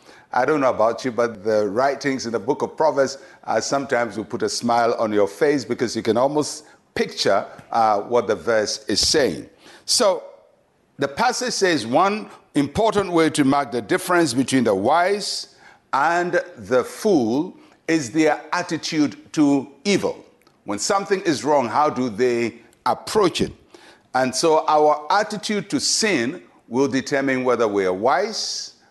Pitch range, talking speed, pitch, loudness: 120-170 Hz, 160 wpm, 140 Hz, -21 LUFS